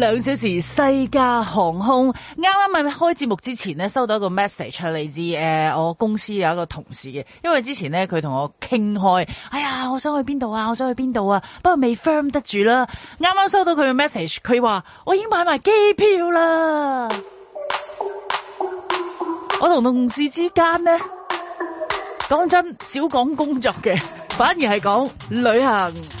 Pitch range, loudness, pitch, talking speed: 205-335 Hz, -20 LUFS, 260 Hz, 265 characters per minute